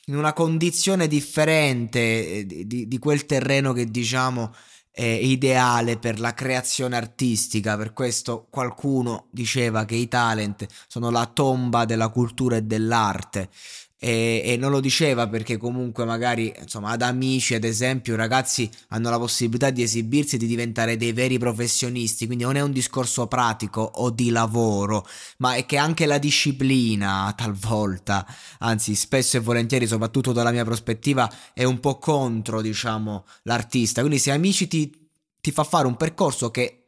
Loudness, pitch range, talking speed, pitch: -22 LUFS, 115-130 Hz, 160 wpm, 120 Hz